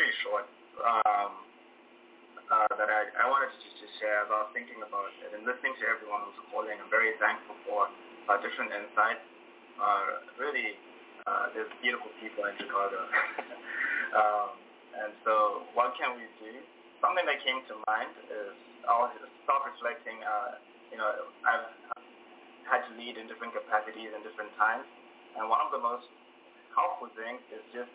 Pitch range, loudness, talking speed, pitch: 105-130 Hz, -31 LUFS, 160 wpm, 115 Hz